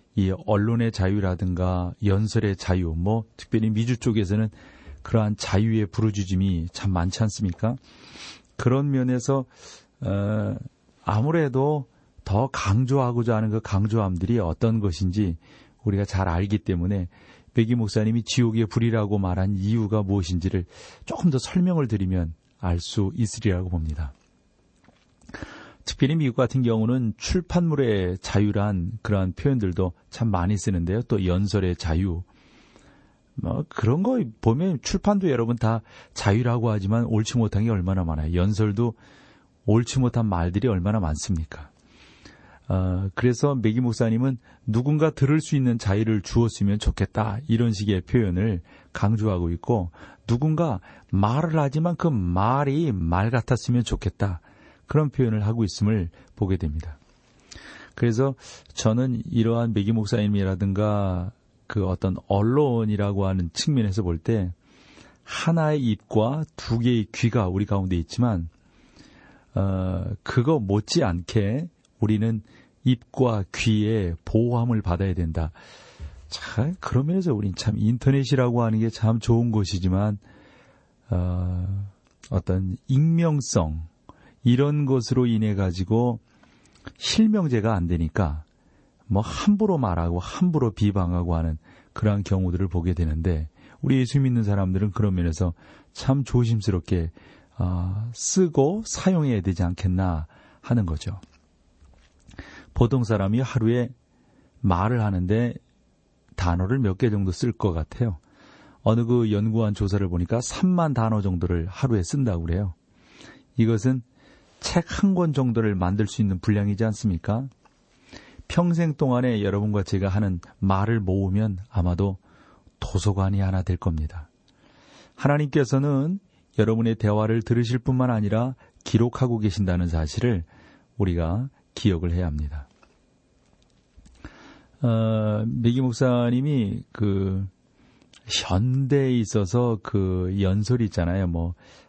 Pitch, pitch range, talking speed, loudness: 105 Hz, 95-120 Hz, 270 characters per minute, -24 LUFS